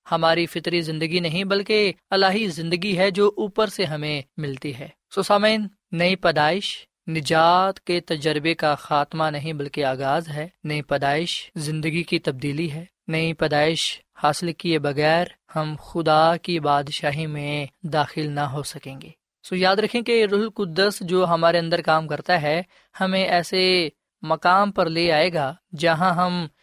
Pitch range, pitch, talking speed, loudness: 150-185 Hz, 165 Hz, 160 wpm, -22 LUFS